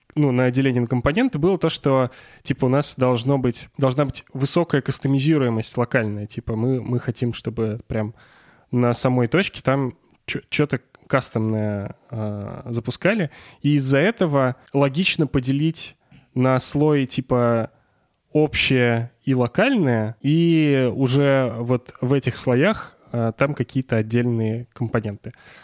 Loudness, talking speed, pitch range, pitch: -21 LUFS, 125 wpm, 120-140 Hz, 130 Hz